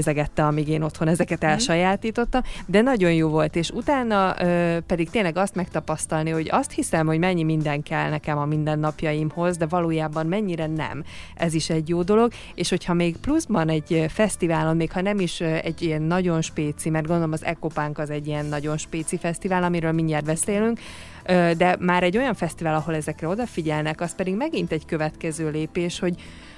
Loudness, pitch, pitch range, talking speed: -23 LUFS, 165 Hz, 155-180 Hz, 175 wpm